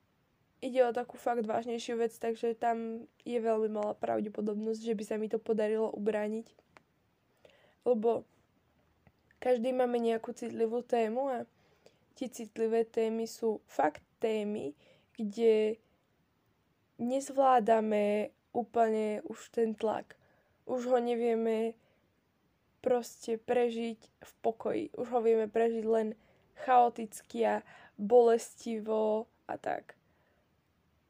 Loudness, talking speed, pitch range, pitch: -32 LUFS, 105 wpm, 220-240 Hz, 230 Hz